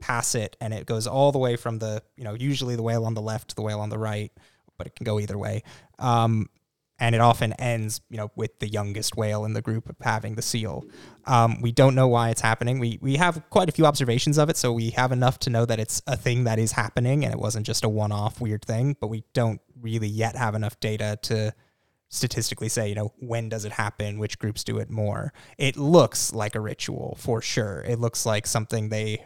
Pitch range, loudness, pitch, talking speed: 110-125 Hz, -25 LUFS, 115 Hz, 240 wpm